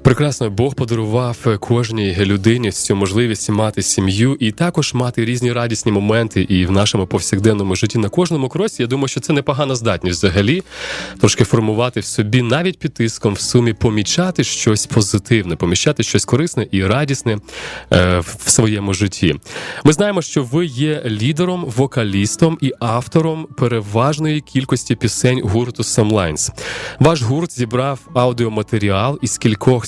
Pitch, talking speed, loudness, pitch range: 120 Hz, 145 wpm, -16 LUFS, 105-135 Hz